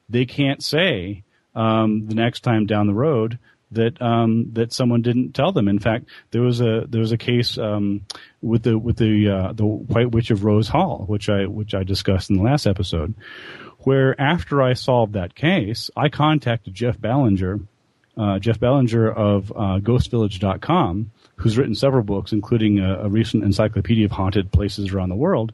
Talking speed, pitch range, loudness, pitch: 185 wpm, 100-120 Hz, -20 LUFS, 110 Hz